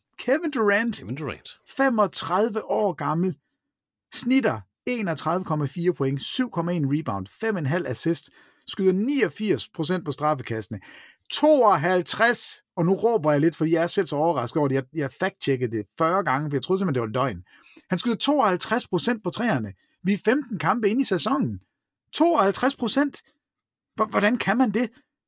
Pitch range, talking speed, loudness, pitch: 150-230 Hz, 145 wpm, -24 LUFS, 185 Hz